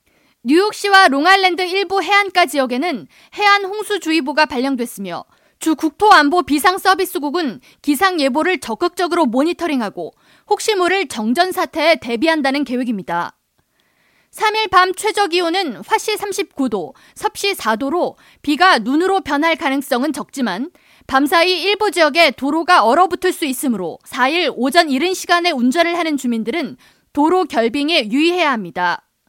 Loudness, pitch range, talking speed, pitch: -16 LUFS, 270-370 Hz, 315 characters per minute, 330 Hz